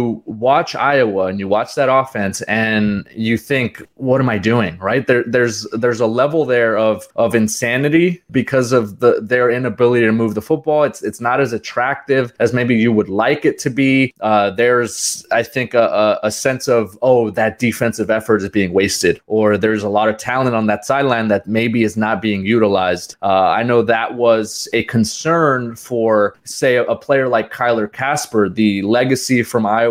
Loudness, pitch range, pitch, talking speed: -16 LUFS, 110-125 Hz, 115 Hz, 195 wpm